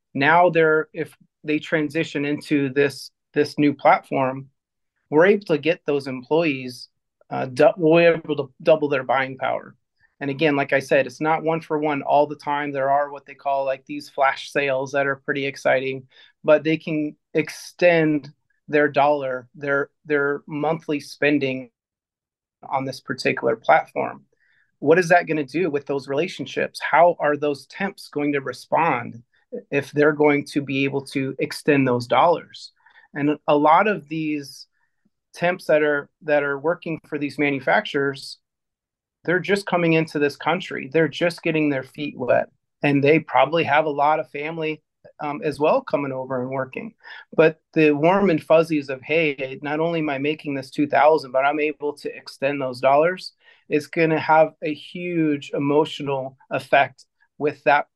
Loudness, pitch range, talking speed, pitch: -21 LUFS, 140-160 Hz, 165 wpm, 150 Hz